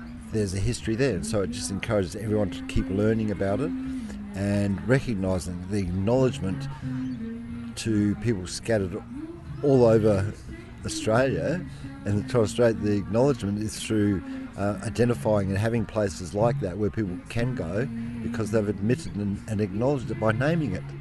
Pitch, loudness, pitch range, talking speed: 110 Hz, -26 LUFS, 100-120 Hz, 150 wpm